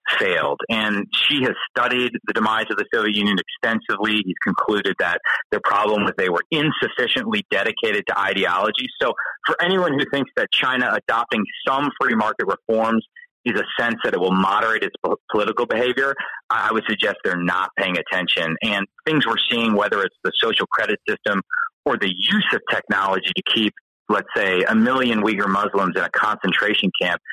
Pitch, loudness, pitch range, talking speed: 125 Hz, -20 LUFS, 105-160 Hz, 175 wpm